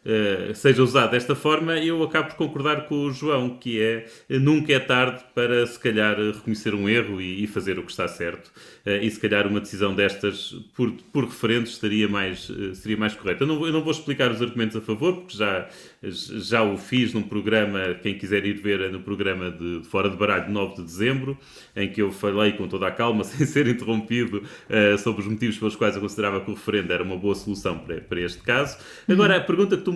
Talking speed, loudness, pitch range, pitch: 220 wpm, -24 LUFS, 100-125 Hz, 110 Hz